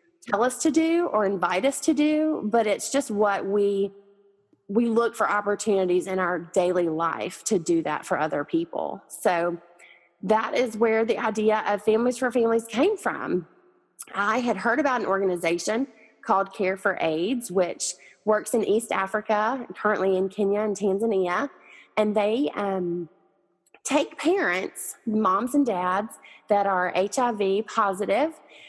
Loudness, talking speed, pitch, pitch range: -25 LUFS, 150 wpm, 210 Hz, 190-240 Hz